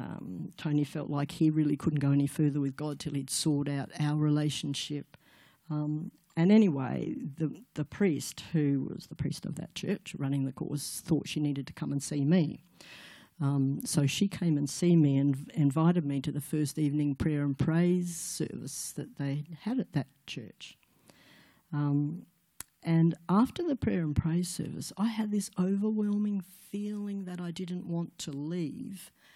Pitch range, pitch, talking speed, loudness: 145-180 Hz, 155 Hz, 175 wpm, -31 LUFS